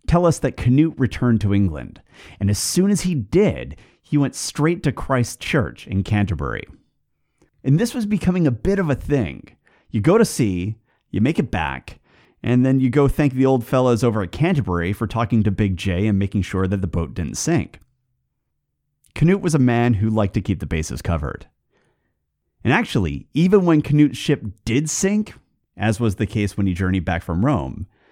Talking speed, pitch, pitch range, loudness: 195 wpm, 120 Hz, 100-145 Hz, -20 LUFS